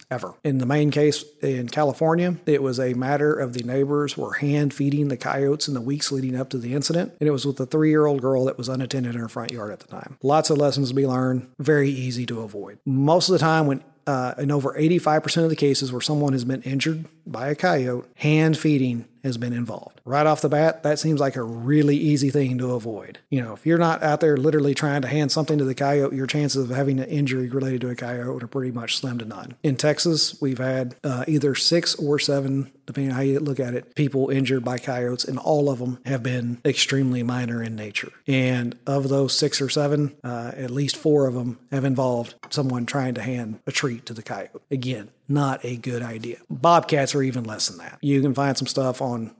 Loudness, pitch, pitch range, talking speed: -23 LUFS, 135 Hz, 125-150 Hz, 235 wpm